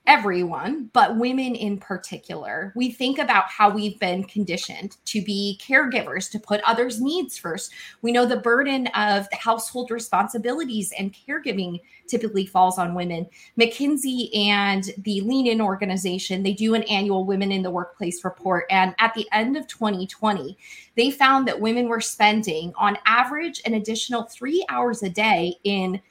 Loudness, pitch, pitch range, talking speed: -22 LUFS, 210 Hz, 195-240 Hz, 160 wpm